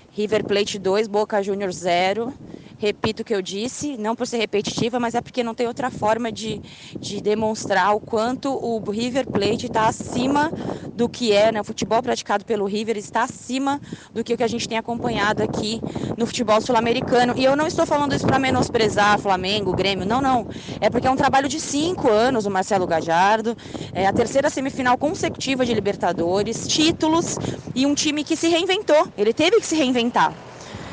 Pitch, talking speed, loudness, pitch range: 230 Hz, 185 wpm, -21 LUFS, 210-260 Hz